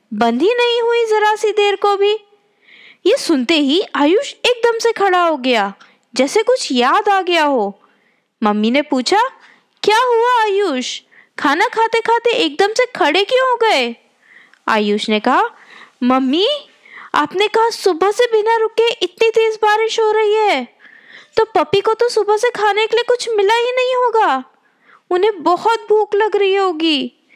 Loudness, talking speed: -15 LUFS, 165 wpm